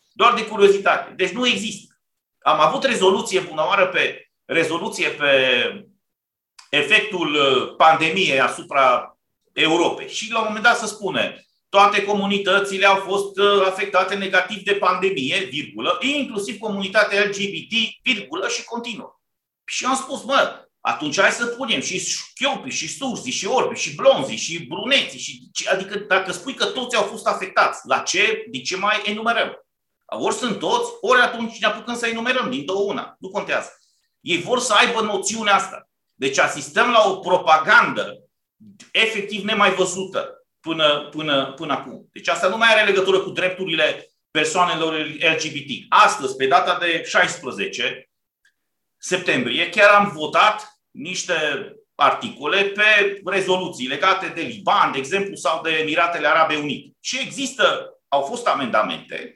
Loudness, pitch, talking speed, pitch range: -19 LUFS, 200 Hz, 145 wpm, 180-235 Hz